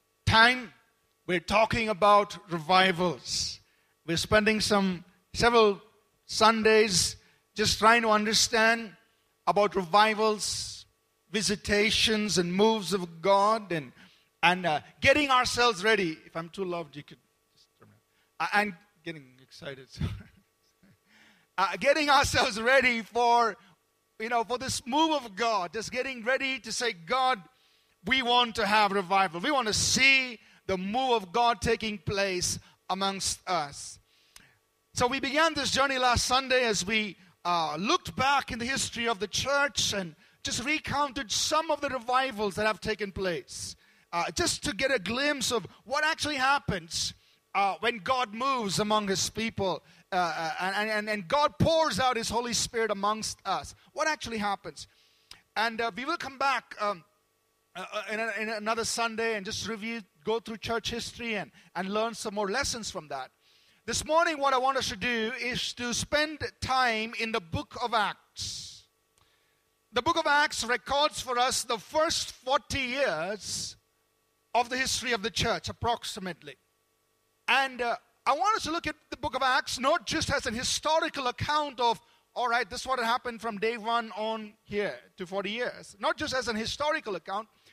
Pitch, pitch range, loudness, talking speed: 225 Hz, 205-255 Hz, -27 LUFS, 160 wpm